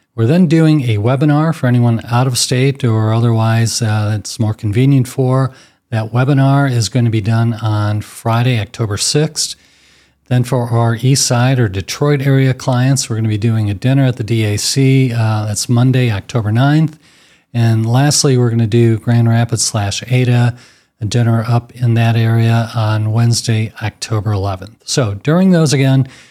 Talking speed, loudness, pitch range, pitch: 170 wpm, -14 LUFS, 110-130 Hz, 115 Hz